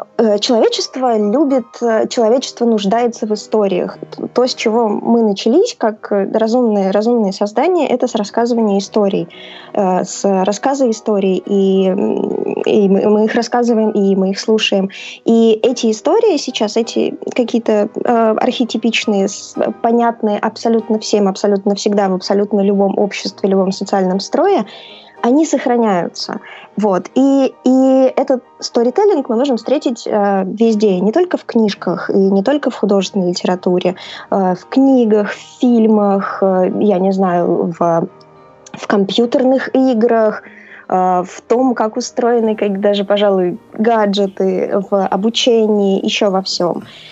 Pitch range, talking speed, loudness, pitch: 200-240 Hz, 125 wpm, -14 LUFS, 220 Hz